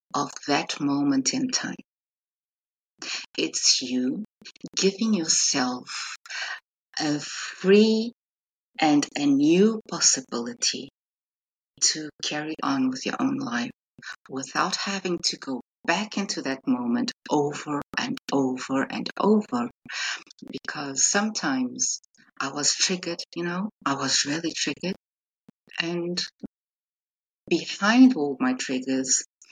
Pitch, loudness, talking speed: 175 Hz, -25 LUFS, 105 wpm